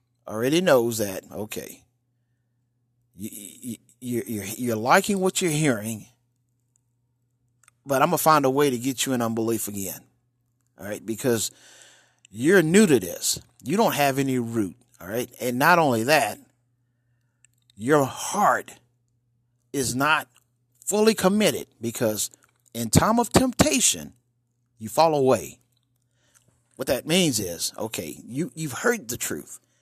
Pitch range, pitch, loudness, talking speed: 120-140 Hz, 120 Hz, -23 LUFS, 135 wpm